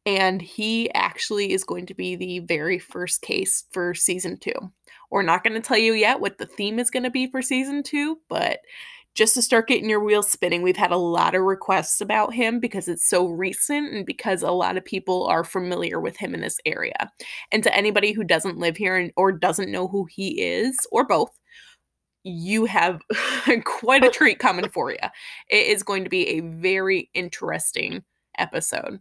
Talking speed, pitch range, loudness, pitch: 200 wpm, 180-245 Hz, -22 LUFS, 200 Hz